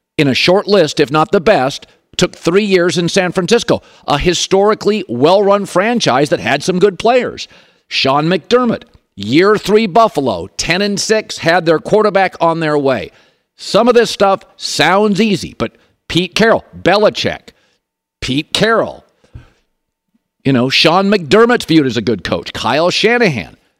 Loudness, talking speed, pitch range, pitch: -13 LUFS, 150 wpm, 160-210 Hz, 185 Hz